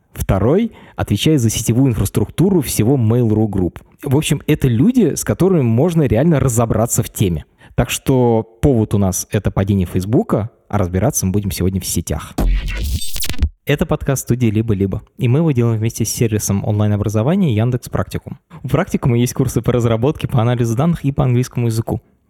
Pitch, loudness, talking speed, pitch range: 115 Hz, -17 LUFS, 165 wpm, 105-140 Hz